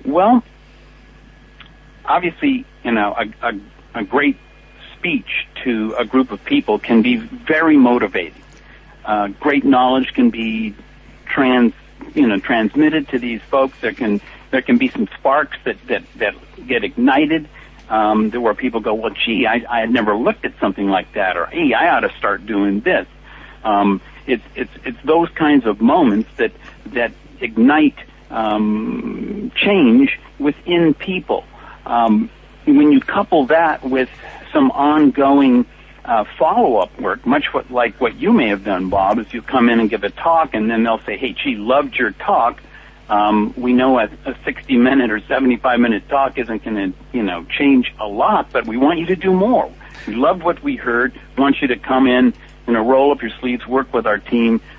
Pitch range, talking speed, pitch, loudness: 115-165 Hz, 180 wpm, 130 Hz, -16 LUFS